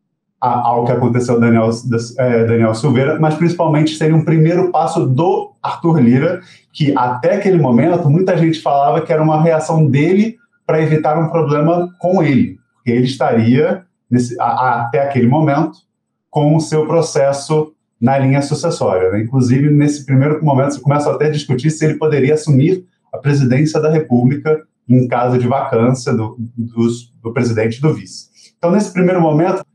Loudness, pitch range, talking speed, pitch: -14 LUFS, 125-160 Hz, 165 wpm, 150 Hz